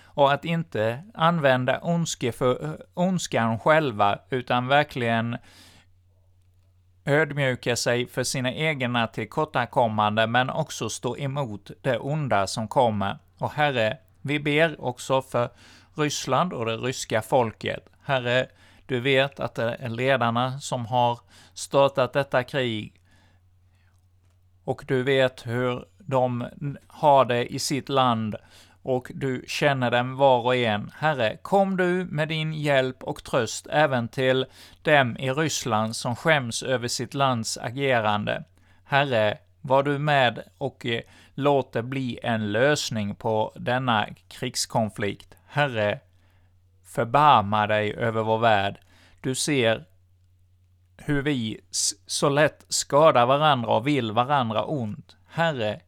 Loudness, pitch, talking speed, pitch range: -24 LUFS, 125 Hz, 120 wpm, 105-140 Hz